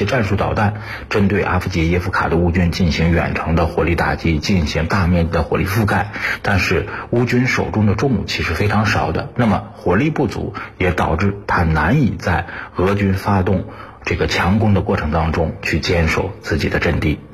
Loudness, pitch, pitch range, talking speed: -17 LUFS, 95 Hz, 85-100 Hz, 285 characters per minute